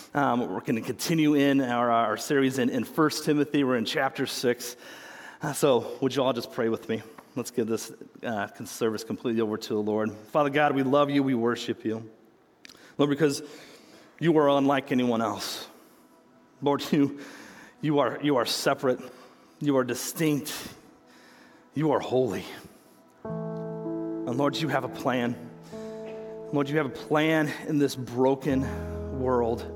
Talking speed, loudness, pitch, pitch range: 155 wpm, -27 LUFS, 135 Hz, 120-150 Hz